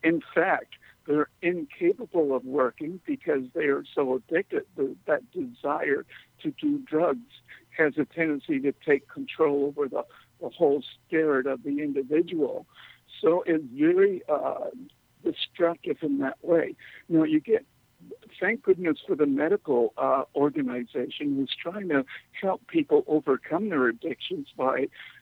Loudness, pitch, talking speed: -27 LUFS, 165 Hz, 140 wpm